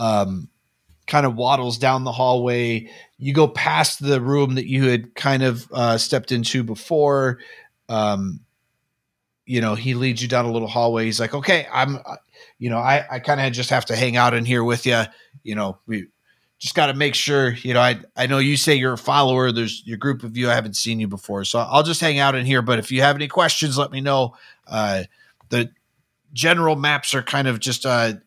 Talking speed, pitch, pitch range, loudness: 220 wpm, 125 Hz, 115-140 Hz, -20 LUFS